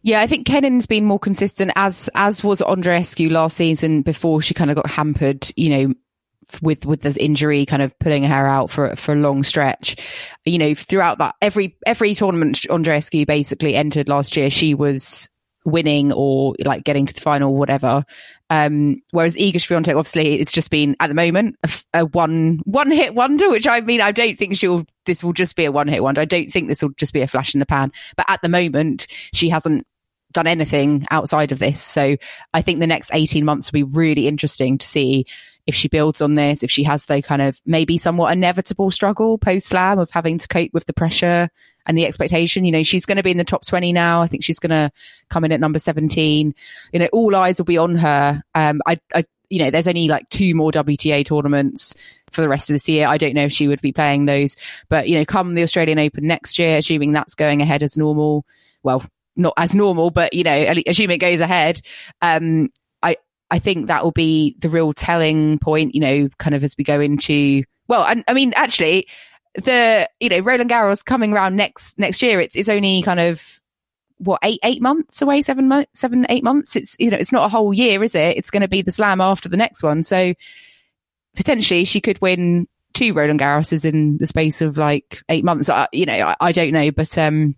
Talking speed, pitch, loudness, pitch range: 225 wpm, 160 Hz, -17 LUFS, 150-185 Hz